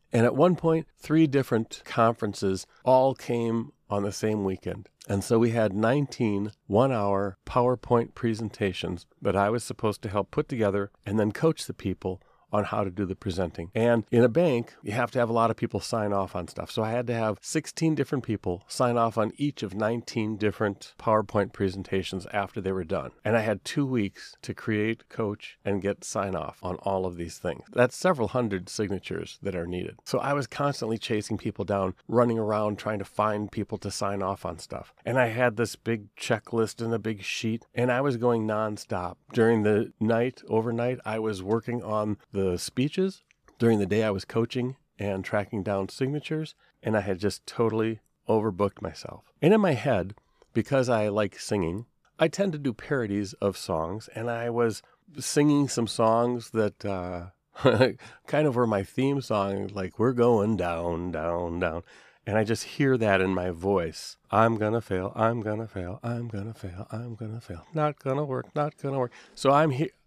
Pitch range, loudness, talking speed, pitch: 100-120 Hz, -27 LUFS, 195 wpm, 110 Hz